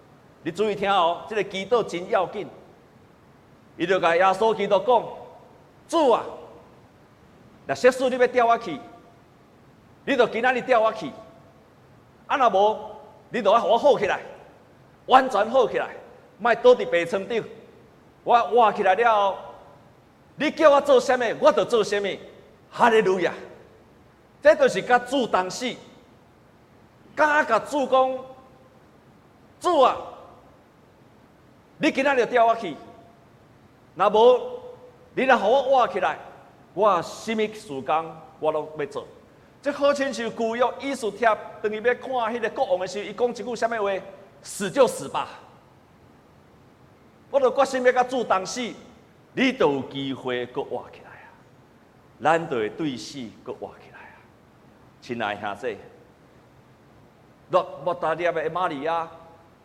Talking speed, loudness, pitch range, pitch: 190 characters per minute, -22 LUFS, 185-260 Hz, 225 Hz